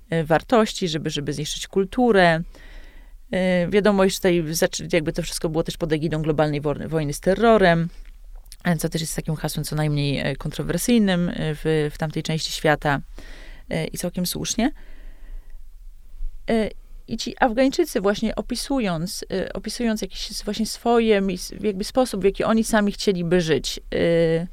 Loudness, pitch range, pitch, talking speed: -22 LUFS, 160-210 Hz, 180 Hz, 130 wpm